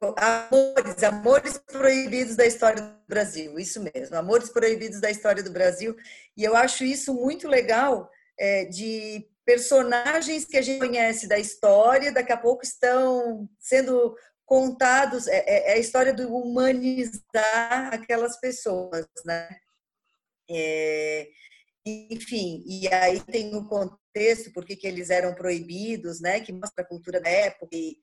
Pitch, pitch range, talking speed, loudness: 225 Hz, 195-255 Hz, 145 wpm, -24 LUFS